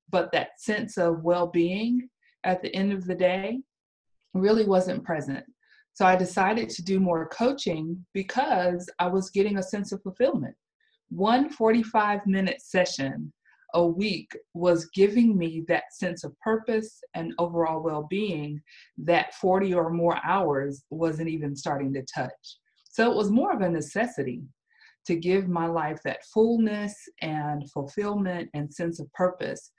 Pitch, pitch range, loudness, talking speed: 185 Hz, 165-220 Hz, -26 LUFS, 155 wpm